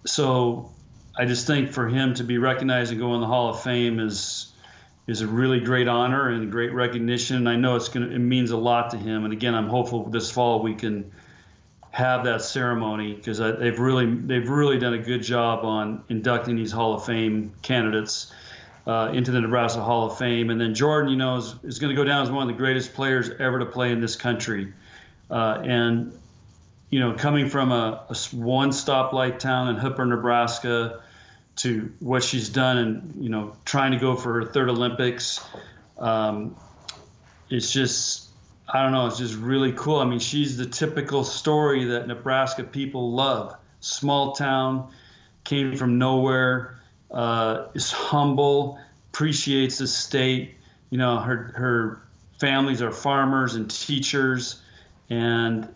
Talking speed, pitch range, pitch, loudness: 175 wpm, 115-130 Hz, 120 Hz, -24 LUFS